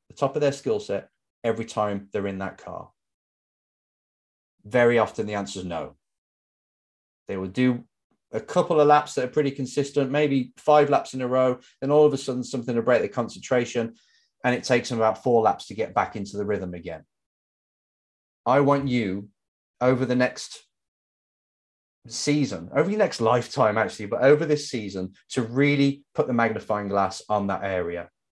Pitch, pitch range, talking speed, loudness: 120 Hz, 100-140 Hz, 180 wpm, -24 LUFS